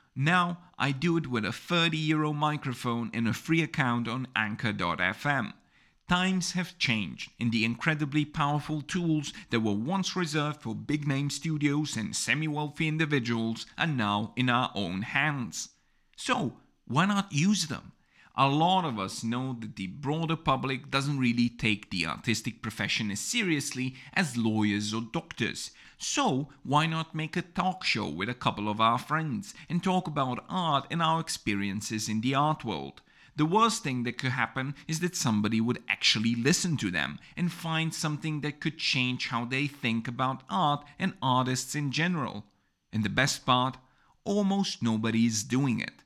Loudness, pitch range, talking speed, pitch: -29 LUFS, 115-160 Hz, 165 wpm, 135 Hz